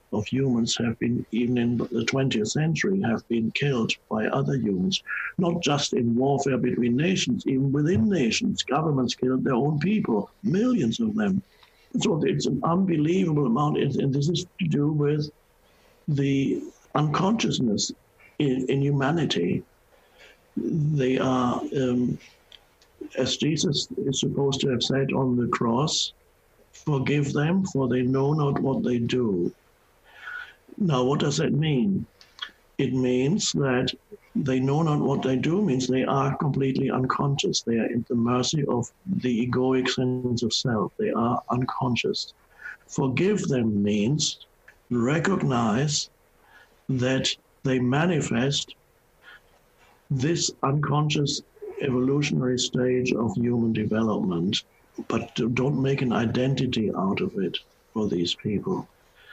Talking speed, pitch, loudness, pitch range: 130 wpm, 135 Hz, -25 LUFS, 125-155 Hz